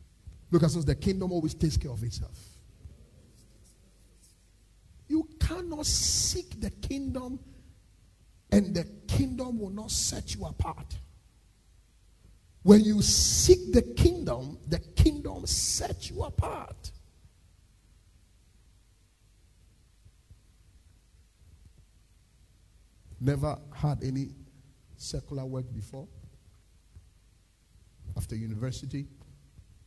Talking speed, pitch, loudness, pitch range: 80 wpm, 100 Hz, -28 LUFS, 90-140 Hz